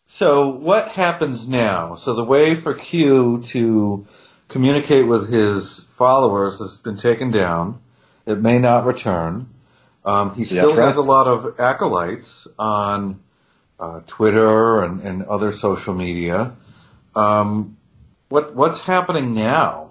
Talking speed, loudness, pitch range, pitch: 130 wpm, -18 LUFS, 100-135 Hz, 115 Hz